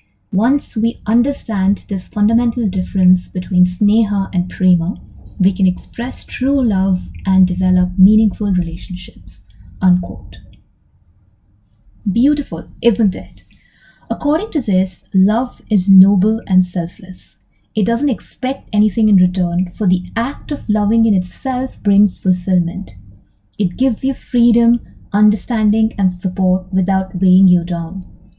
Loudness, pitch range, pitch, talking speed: -15 LUFS, 180-220 Hz, 190 Hz, 120 wpm